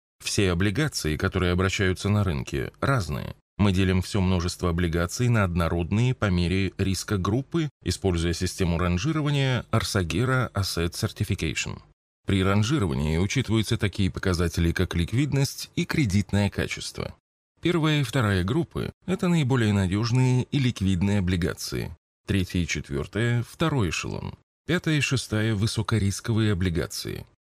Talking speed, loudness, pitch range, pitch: 120 wpm, -25 LUFS, 90-120 Hz, 100 Hz